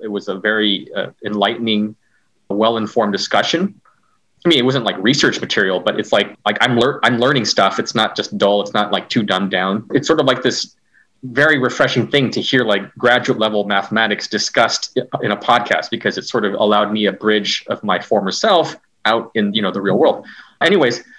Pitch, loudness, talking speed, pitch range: 105 Hz, -16 LUFS, 210 wpm, 100-120 Hz